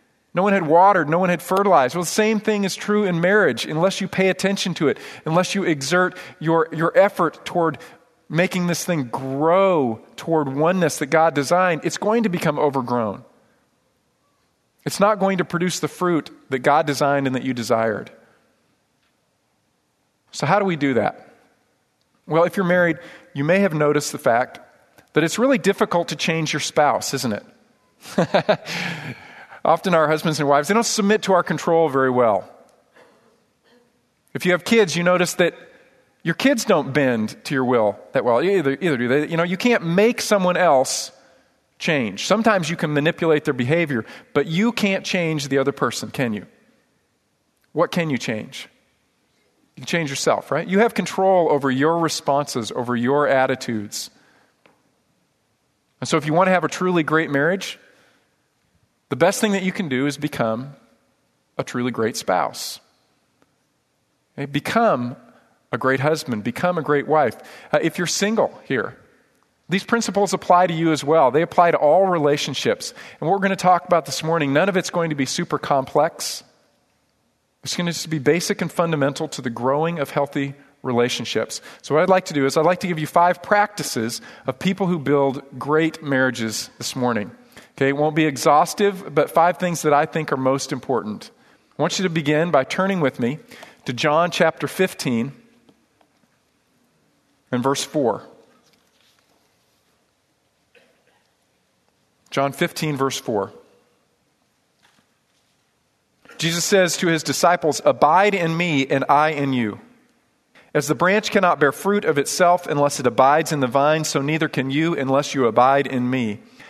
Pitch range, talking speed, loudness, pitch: 140-180 Hz, 170 wpm, -20 LUFS, 160 Hz